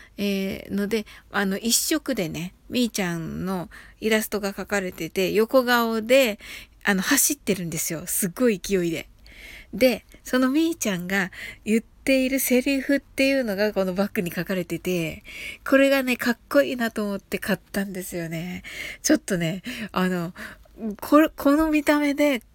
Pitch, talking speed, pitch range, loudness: 210 Hz, 310 characters per minute, 190-265 Hz, -23 LUFS